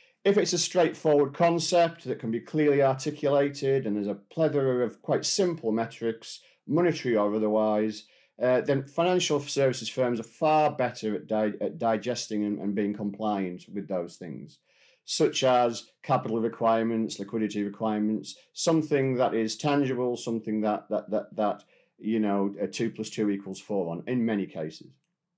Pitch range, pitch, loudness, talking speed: 110-145 Hz, 115 Hz, -27 LUFS, 160 wpm